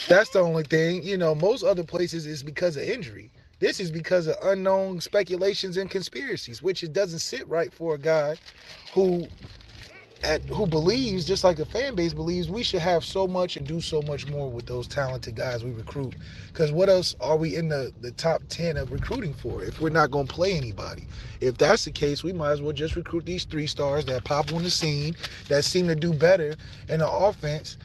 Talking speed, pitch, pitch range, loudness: 215 wpm, 160 Hz, 140-180 Hz, -26 LUFS